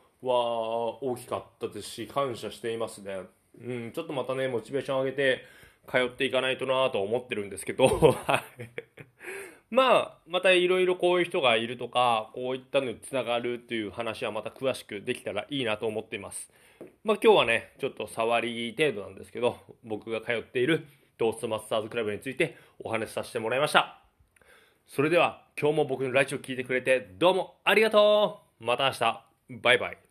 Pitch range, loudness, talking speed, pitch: 115-150 Hz, -27 LUFS, 400 characters per minute, 130 Hz